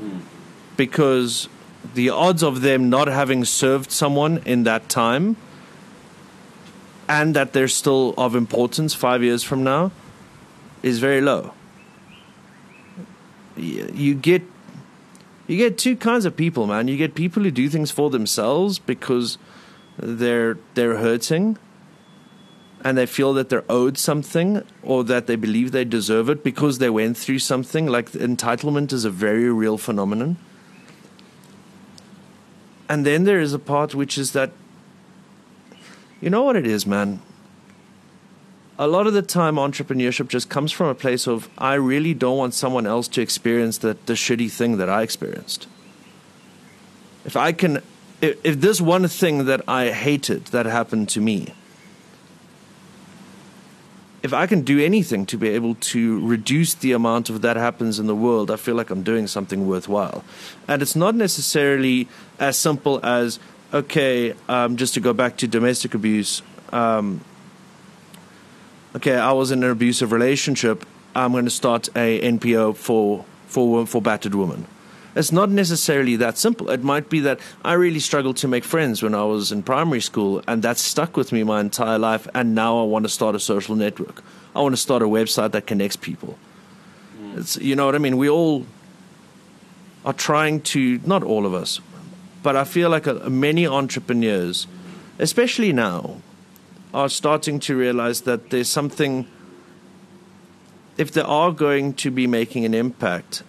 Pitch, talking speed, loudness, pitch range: 135 Hz, 160 wpm, -20 LUFS, 120-170 Hz